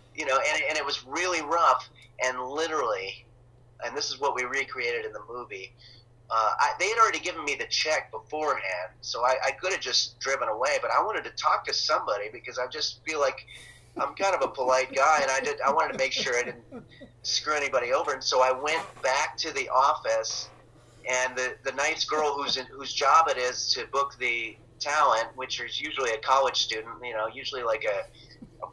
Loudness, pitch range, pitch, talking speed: -27 LUFS, 120-150 Hz, 130 Hz, 215 wpm